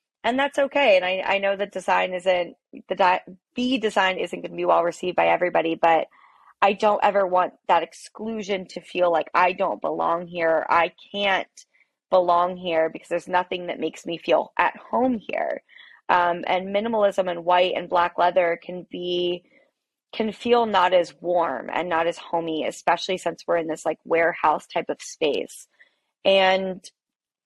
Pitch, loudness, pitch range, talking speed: 180 Hz, -23 LUFS, 170-200 Hz, 175 wpm